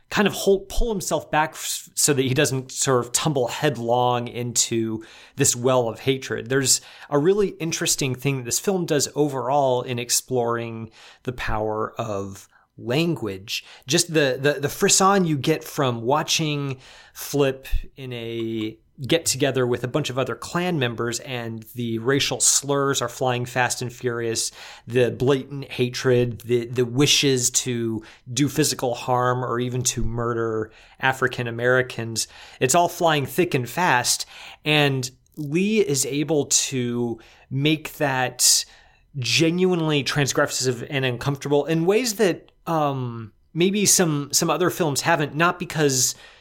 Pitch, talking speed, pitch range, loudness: 130 Hz, 140 wpm, 120-150 Hz, -22 LUFS